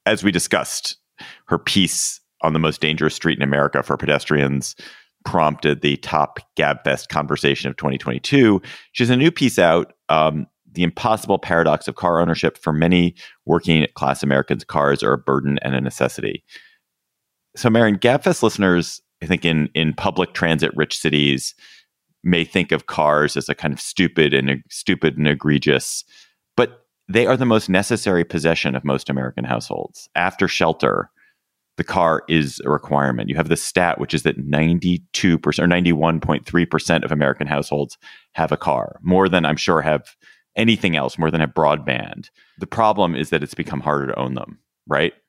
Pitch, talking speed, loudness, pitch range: 80 Hz, 170 wpm, -19 LUFS, 70-90 Hz